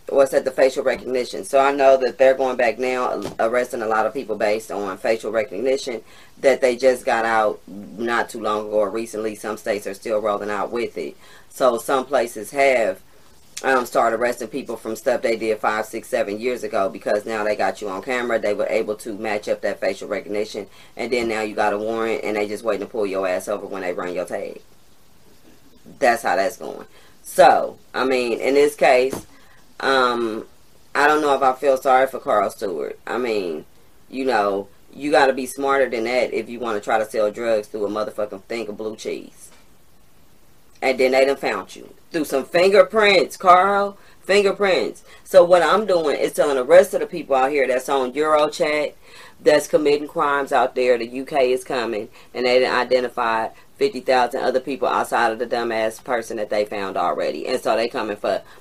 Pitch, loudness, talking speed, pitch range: 125 Hz, -20 LUFS, 205 wpm, 110-135 Hz